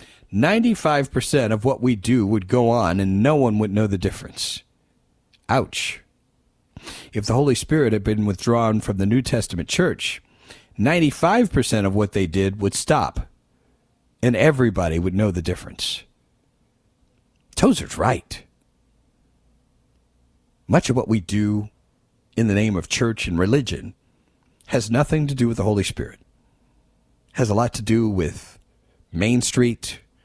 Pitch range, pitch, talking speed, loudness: 100-125 Hz, 110 Hz, 140 wpm, -21 LUFS